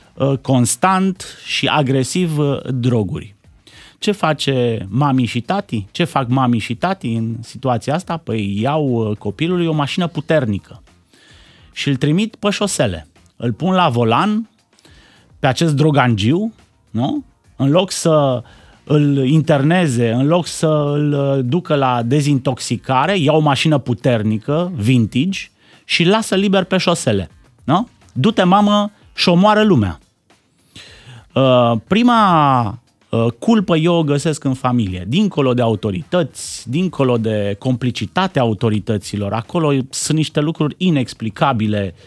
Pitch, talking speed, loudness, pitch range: 135 Hz, 120 wpm, -16 LUFS, 115-170 Hz